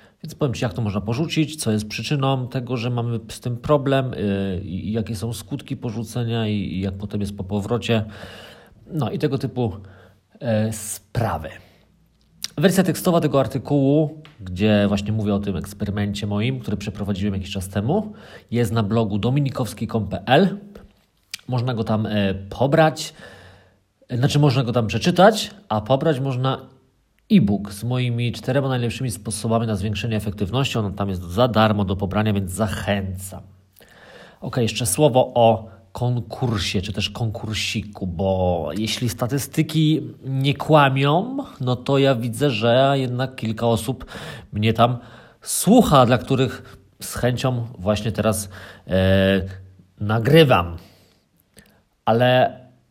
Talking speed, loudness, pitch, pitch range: 135 wpm, -21 LUFS, 115 Hz, 100-135 Hz